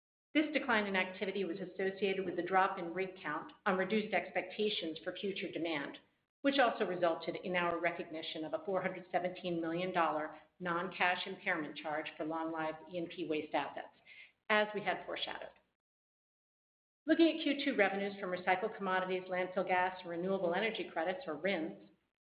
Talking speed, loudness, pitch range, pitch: 155 wpm, -36 LUFS, 170-195 Hz, 180 Hz